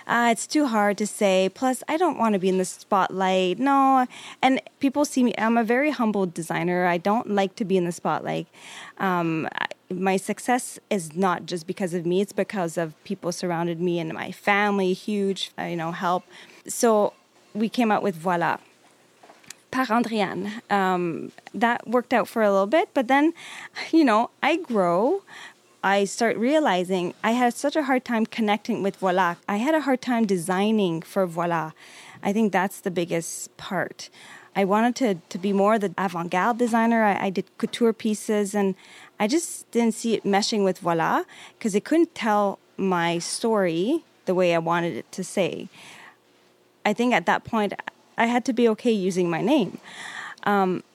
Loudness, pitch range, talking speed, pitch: -24 LUFS, 180-235 Hz, 180 wpm, 200 Hz